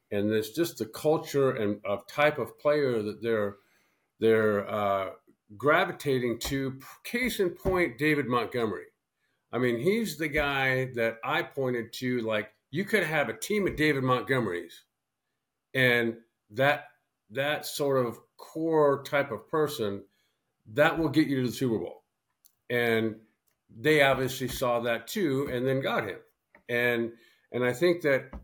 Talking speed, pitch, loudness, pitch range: 150 wpm, 130 Hz, -28 LUFS, 115-150 Hz